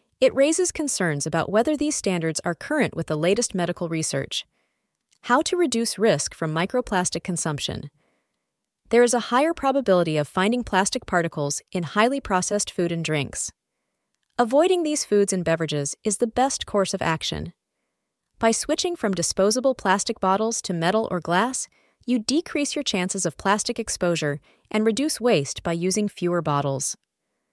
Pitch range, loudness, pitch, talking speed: 170-245 Hz, -23 LUFS, 200 Hz, 155 wpm